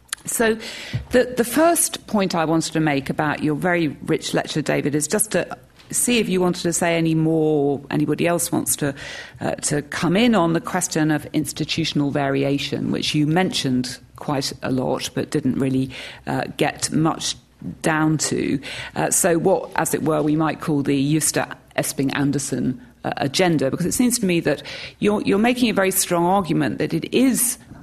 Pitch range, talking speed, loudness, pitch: 140-180 Hz, 185 wpm, -21 LUFS, 155 Hz